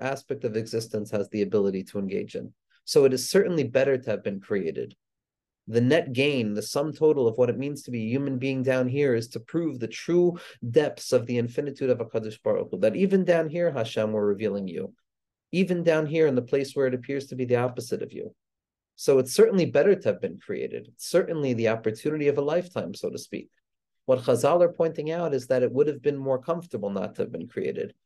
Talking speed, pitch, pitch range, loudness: 225 wpm, 135 Hz, 120-165 Hz, -26 LUFS